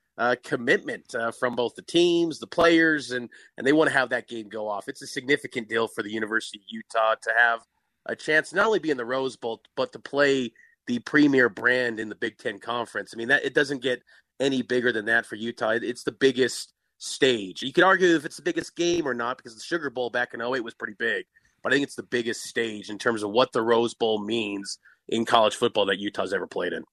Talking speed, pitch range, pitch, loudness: 245 wpm, 115-145 Hz, 125 Hz, -25 LUFS